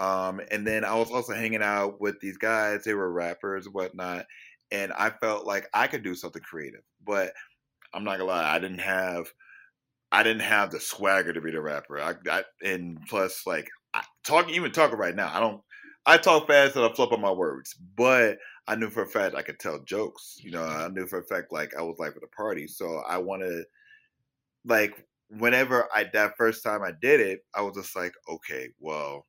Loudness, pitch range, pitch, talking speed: -26 LUFS, 90-115 Hz, 100 Hz, 215 wpm